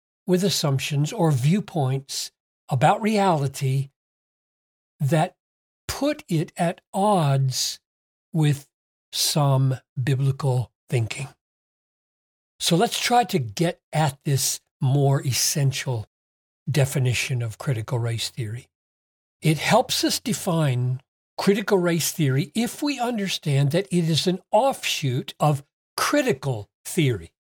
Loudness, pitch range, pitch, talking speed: -23 LUFS, 130-175 Hz, 140 Hz, 100 wpm